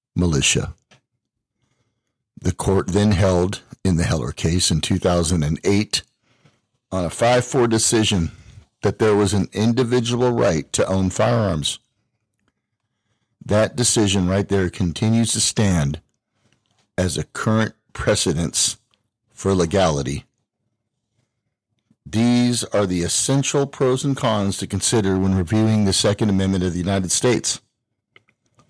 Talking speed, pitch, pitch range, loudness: 115 wpm, 110 Hz, 95-115 Hz, -19 LUFS